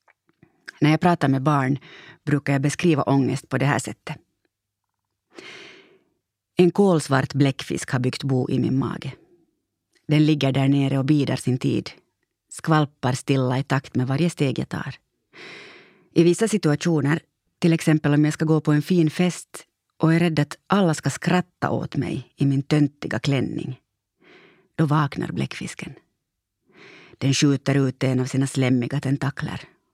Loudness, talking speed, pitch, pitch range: -22 LUFS, 150 wpm, 145 Hz, 135-170 Hz